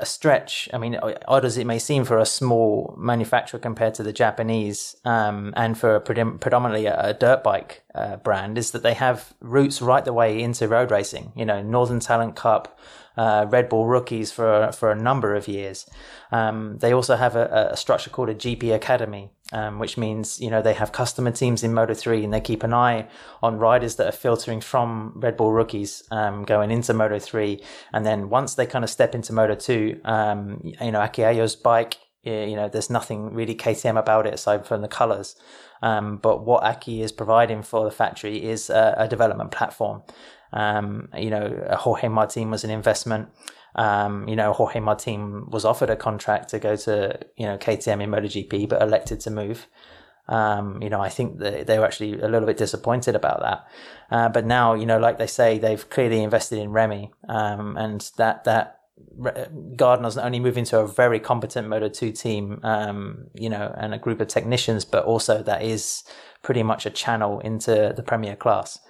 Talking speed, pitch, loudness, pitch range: 200 wpm, 110 Hz, -22 LUFS, 105-115 Hz